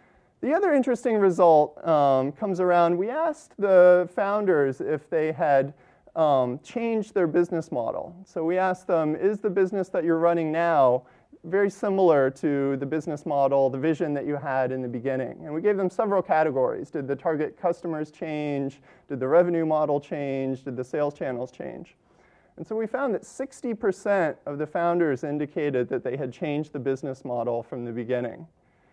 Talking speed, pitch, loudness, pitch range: 175 wpm, 155 Hz, -25 LUFS, 140-185 Hz